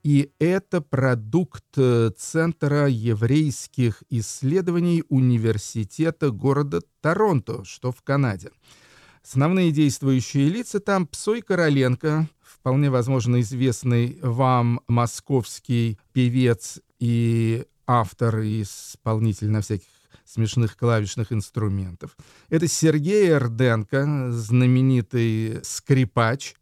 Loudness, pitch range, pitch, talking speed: -22 LUFS, 115-145 Hz, 125 Hz, 85 wpm